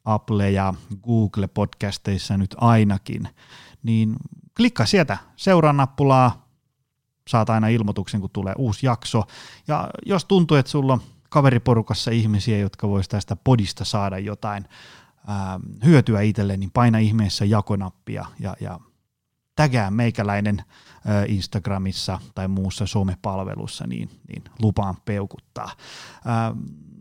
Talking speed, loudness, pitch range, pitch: 115 wpm, -22 LUFS, 100-120 Hz, 110 Hz